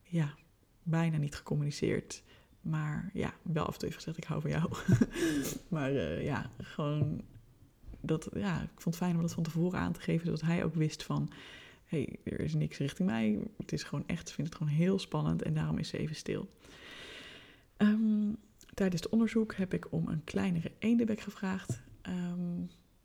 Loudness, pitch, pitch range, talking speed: -34 LUFS, 165 Hz, 150-195 Hz, 190 wpm